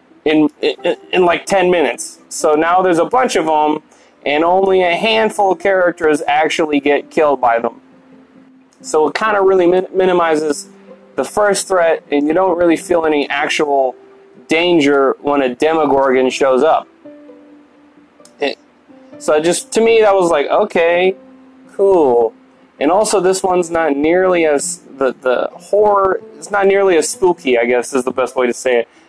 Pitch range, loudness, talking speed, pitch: 150-215 Hz, -14 LUFS, 165 wpm, 180 Hz